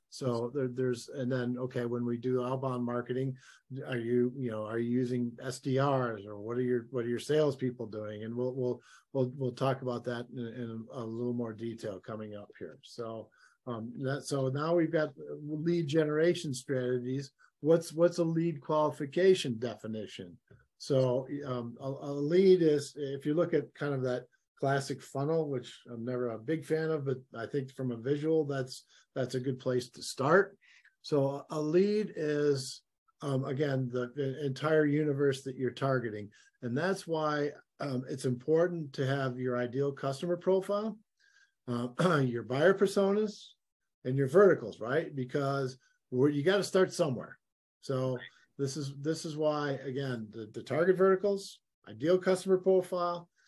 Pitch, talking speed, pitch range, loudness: 135 Hz, 170 wpm, 125-155 Hz, -32 LUFS